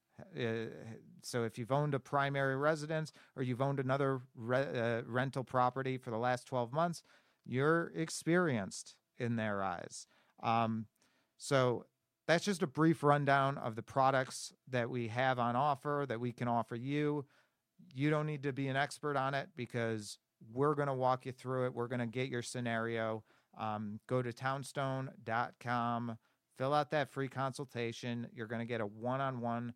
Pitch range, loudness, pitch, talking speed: 120-140 Hz, -36 LUFS, 130 Hz, 170 wpm